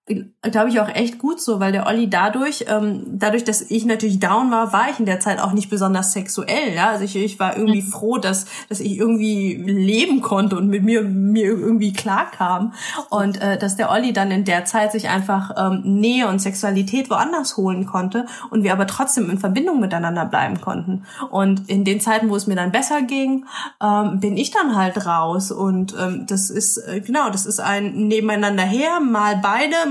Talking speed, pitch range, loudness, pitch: 205 wpm, 195-225 Hz, -19 LUFS, 210 Hz